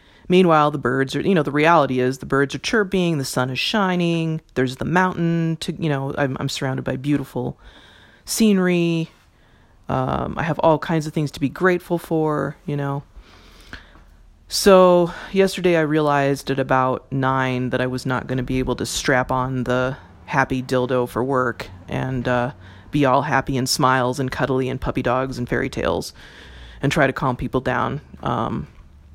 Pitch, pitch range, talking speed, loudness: 130 Hz, 125-155 Hz, 180 wpm, -20 LUFS